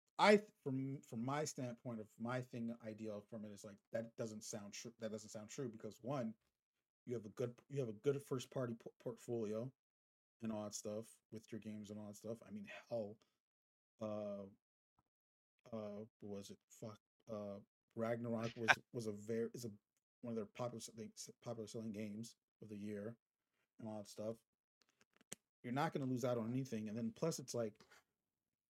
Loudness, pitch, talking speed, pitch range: -45 LUFS, 115 Hz, 190 wpm, 105-125 Hz